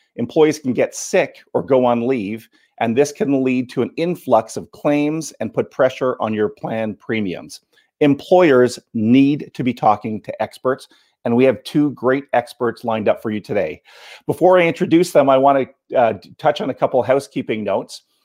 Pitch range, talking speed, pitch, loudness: 120-150 Hz, 185 wpm, 130 Hz, -18 LUFS